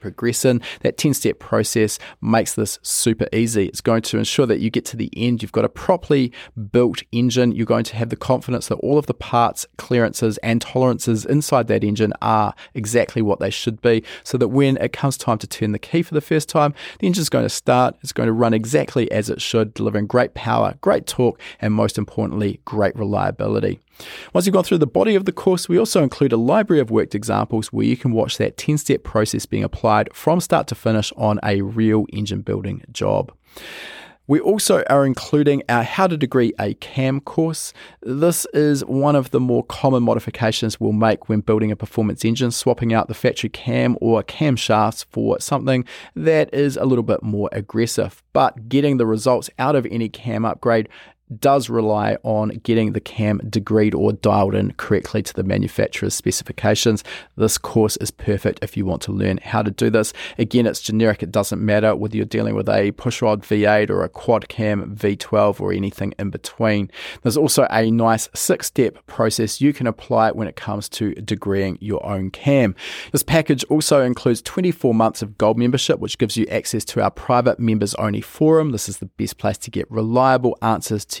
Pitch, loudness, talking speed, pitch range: 115 Hz, -19 LUFS, 200 wpm, 105-130 Hz